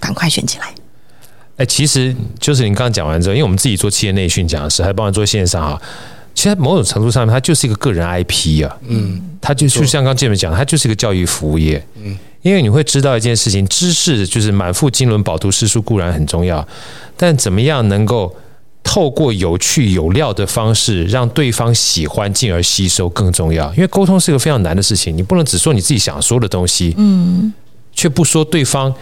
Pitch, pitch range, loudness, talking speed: 110 Hz, 95-135 Hz, -13 LUFS, 335 characters per minute